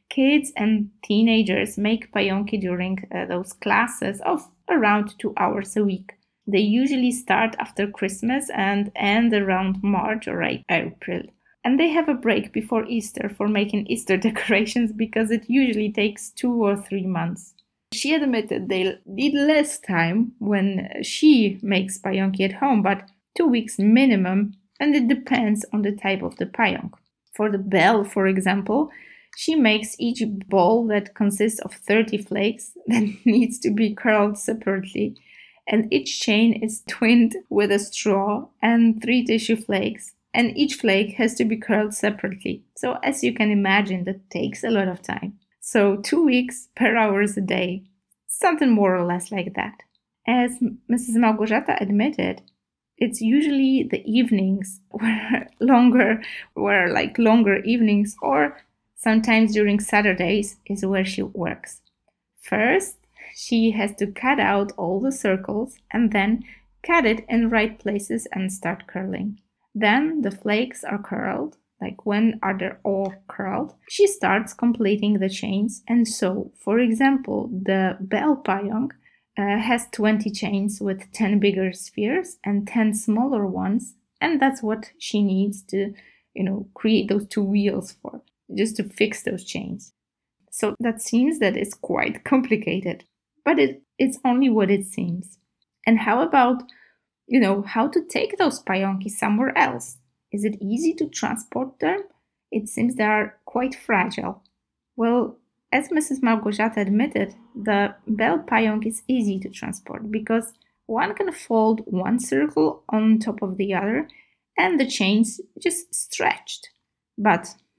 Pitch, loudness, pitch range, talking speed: 215 Hz, -22 LUFS, 200-240 Hz, 150 wpm